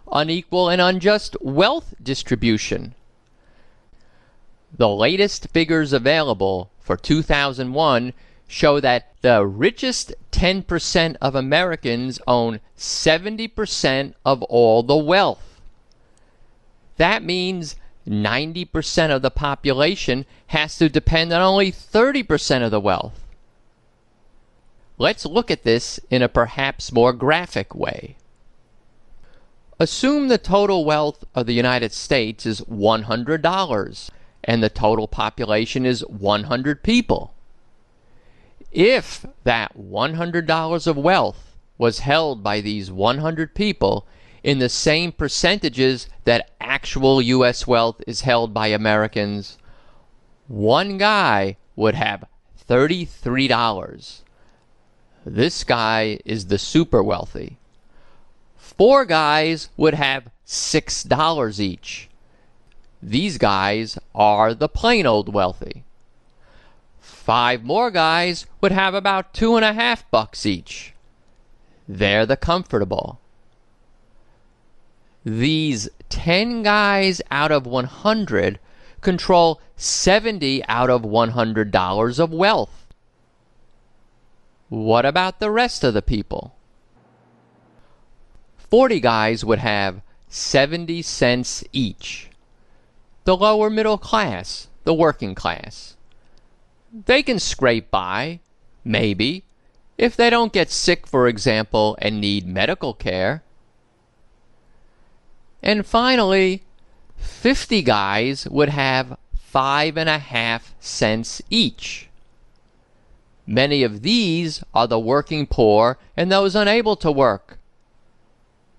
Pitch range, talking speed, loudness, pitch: 115-175 Hz, 100 wpm, -19 LUFS, 135 Hz